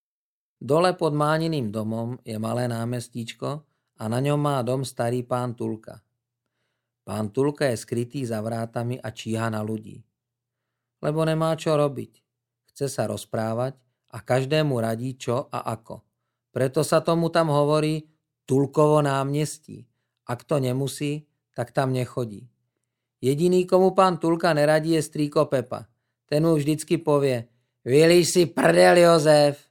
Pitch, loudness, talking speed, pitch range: 130 Hz, -23 LUFS, 135 wpm, 120-150 Hz